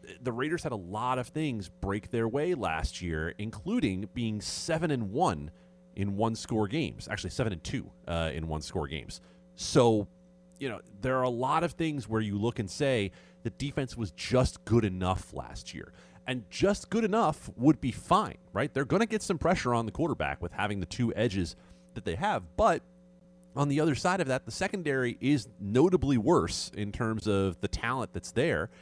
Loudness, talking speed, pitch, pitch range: -30 LUFS, 200 wpm, 115 Hz, 95-140 Hz